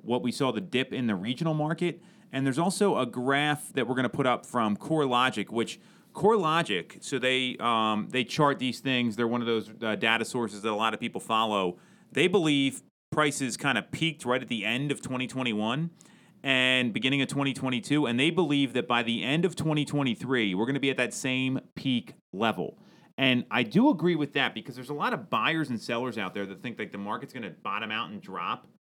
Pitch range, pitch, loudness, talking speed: 120-145 Hz, 130 Hz, -28 LUFS, 220 wpm